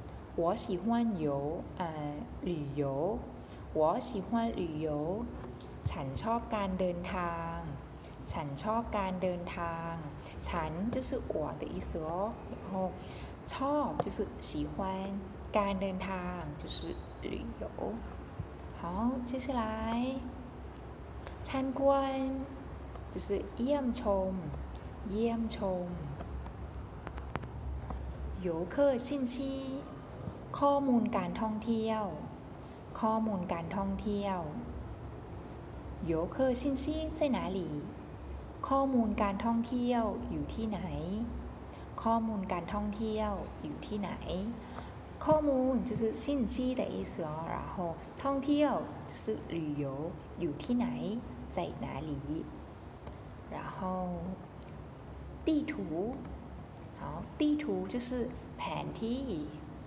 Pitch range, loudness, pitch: 170-245 Hz, -35 LUFS, 210 Hz